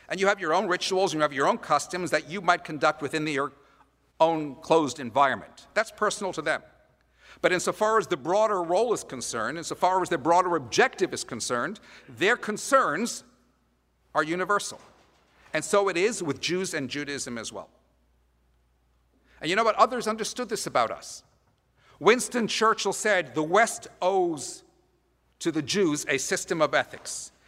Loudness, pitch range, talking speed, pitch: -26 LUFS, 150-205 Hz, 170 wpm, 180 Hz